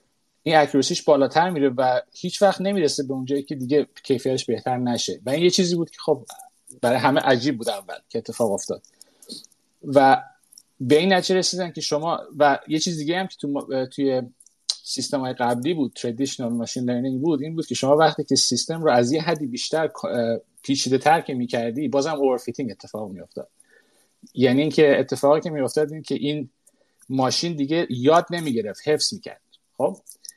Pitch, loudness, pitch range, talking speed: 145 Hz, -22 LUFS, 130-165 Hz, 175 wpm